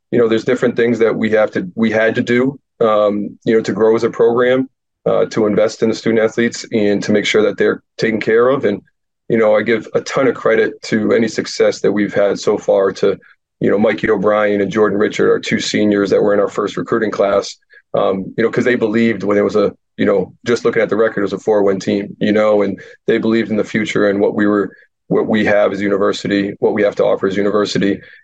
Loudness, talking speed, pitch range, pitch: -15 LUFS, 250 wpm, 100-120 Hz, 110 Hz